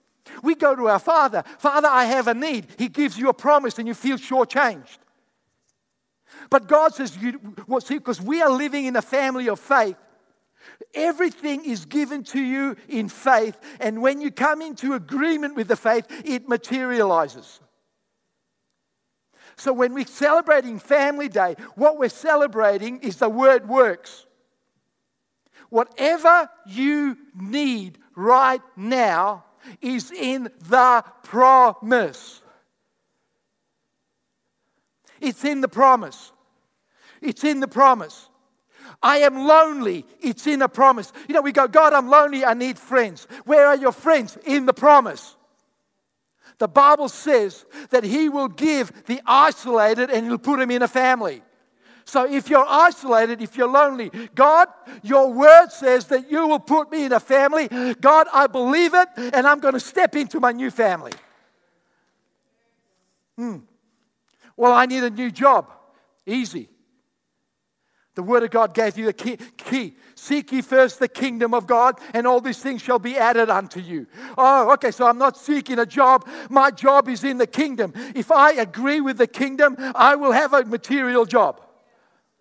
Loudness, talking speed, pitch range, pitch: -18 LUFS, 155 wpm, 240-285 Hz, 260 Hz